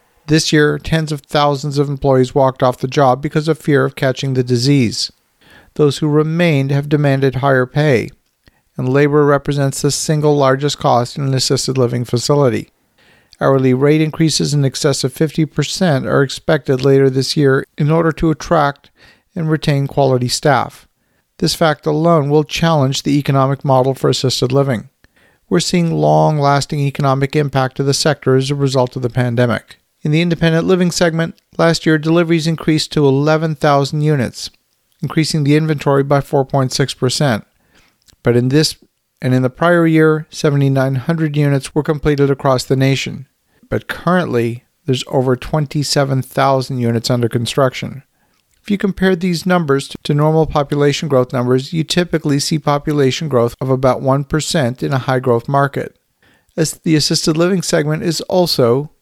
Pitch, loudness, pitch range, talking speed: 145 Hz, -15 LUFS, 135-155 Hz, 155 wpm